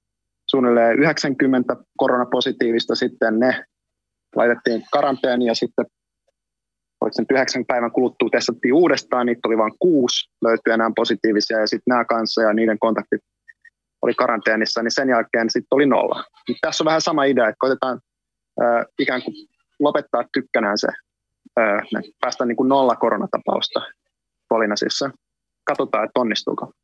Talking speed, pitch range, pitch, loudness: 135 wpm, 115-135 Hz, 120 Hz, -19 LUFS